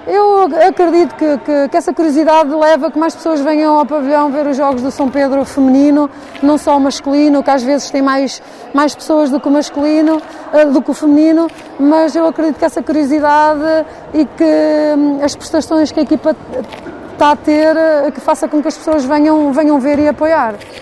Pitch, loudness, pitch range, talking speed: 300 Hz, -12 LUFS, 285-315 Hz, 195 wpm